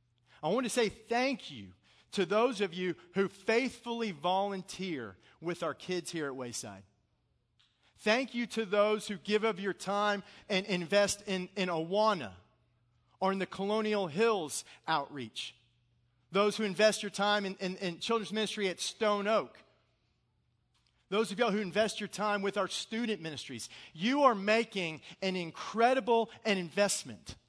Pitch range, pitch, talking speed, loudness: 160-215 Hz, 195 Hz, 155 wpm, -33 LUFS